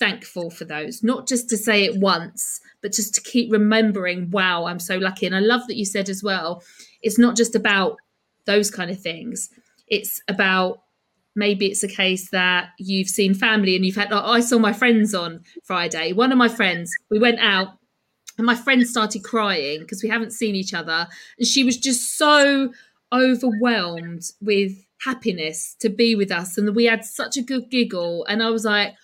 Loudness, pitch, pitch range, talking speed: -20 LUFS, 210 Hz, 185-235 Hz, 195 wpm